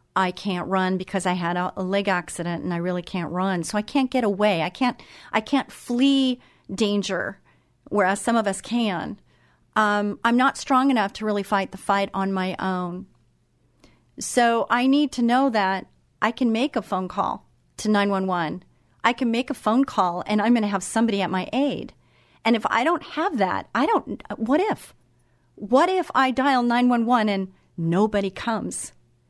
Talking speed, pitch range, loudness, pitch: 185 wpm, 190-245 Hz, -23 LUFS, 210 Hz